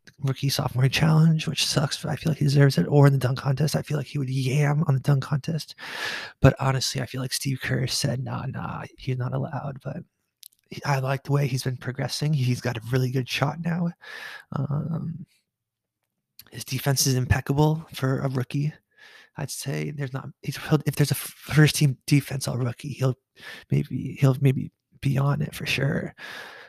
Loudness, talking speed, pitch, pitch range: -25 LUFS, 190 wpm, 140 Hz, 130-155 Hz